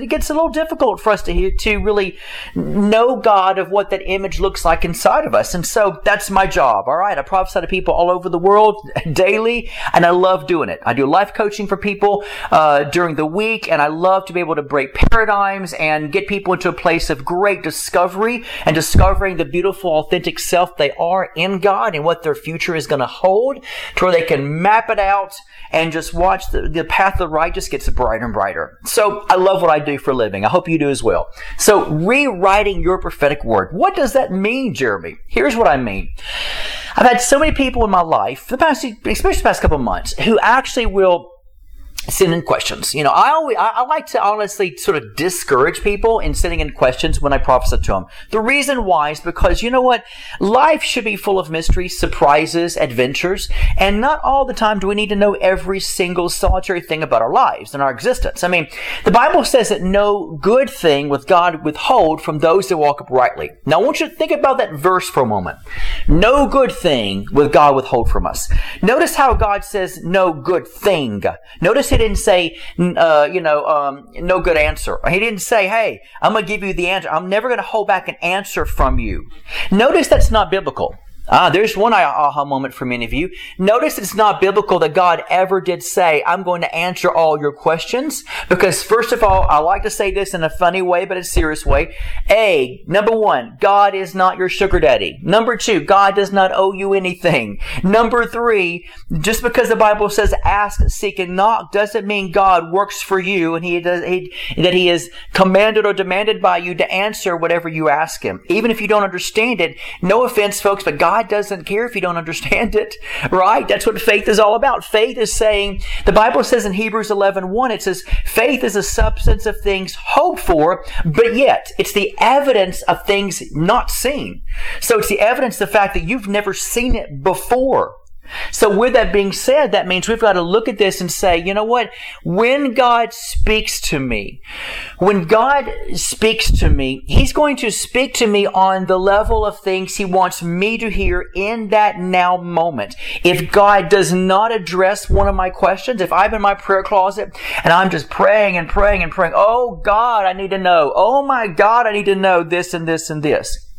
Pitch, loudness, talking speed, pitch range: 195 Hz, -15 LUFS, 215 wpm, 175-220 Hz